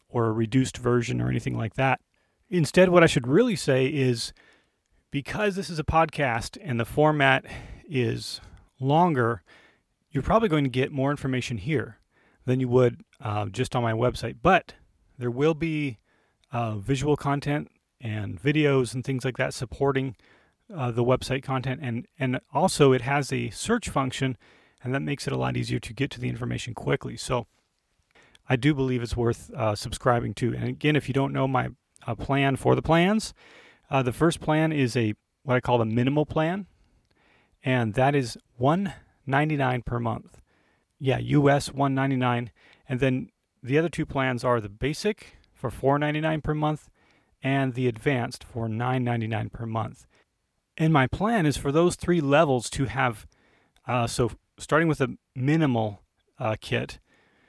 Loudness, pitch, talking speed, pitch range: -26 LUFS, 130 Hz, 170 wpm, 120-145 Hz